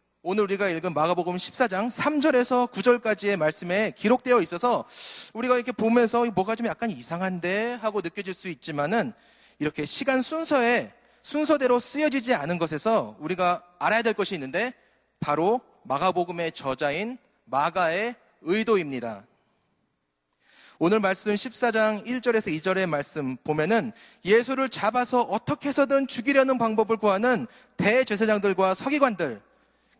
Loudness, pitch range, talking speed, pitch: -25 LUFS, 185-245 Hz, 310 characters per minute, 225 Hz